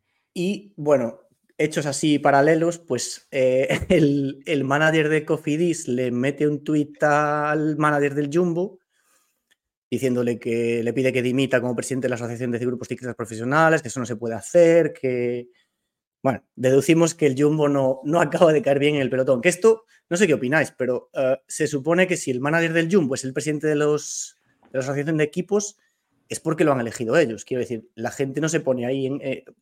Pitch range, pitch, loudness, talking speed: 125-160 Hz, 145 Hz, -22 LUFS, 200 wpm